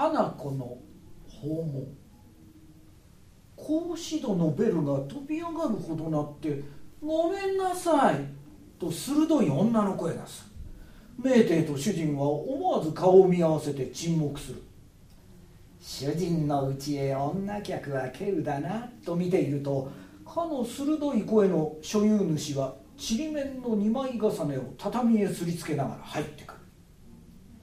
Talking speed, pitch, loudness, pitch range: 240 characters per minute, 165 Hz, -28 LUFS, 140-225 Hz